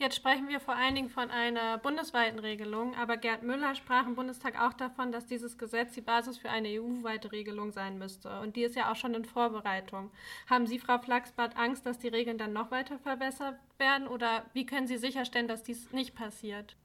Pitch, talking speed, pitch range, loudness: 240 Hz, 210 wpm, 225-260 Hz, -34 LUFS